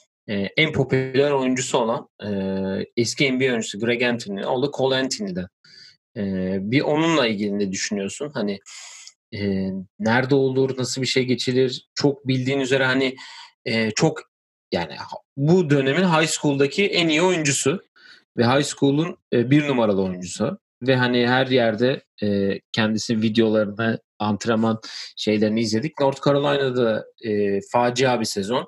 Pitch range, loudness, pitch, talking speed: 105-140 Hz, -21 LUFS, 125 Hz, 130 wpm